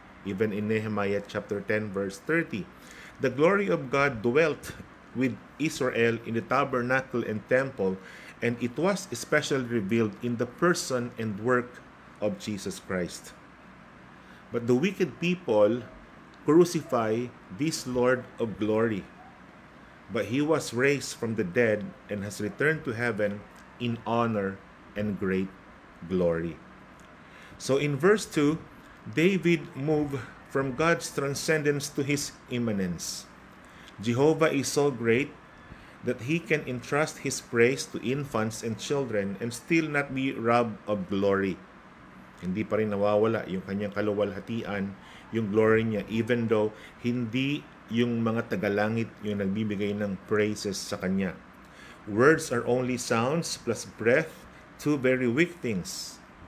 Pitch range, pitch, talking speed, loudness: 105-140 Hz, 120 Hz, 130 wpm, -28 LUFS